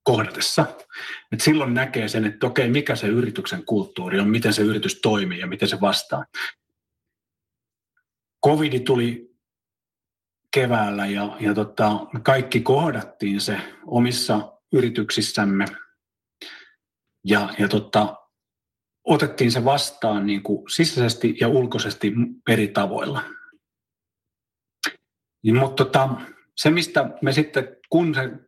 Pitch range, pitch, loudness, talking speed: 105-135 Hz, 120 Hz, -22 LUFS, 100 wpm